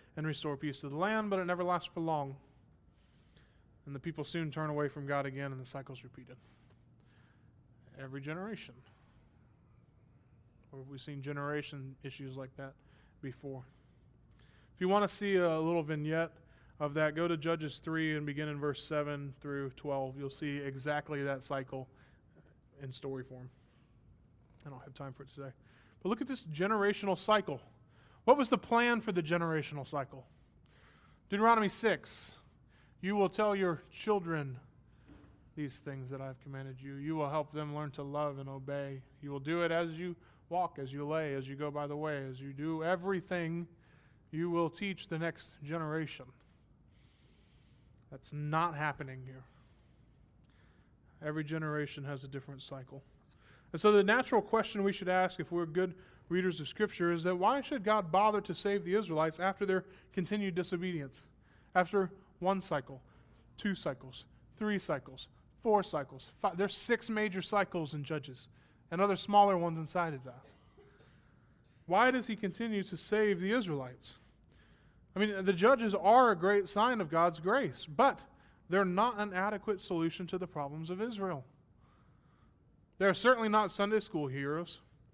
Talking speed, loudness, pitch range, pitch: 160 wpm, -34 LUFS, 135-185 Hz, 150 Hz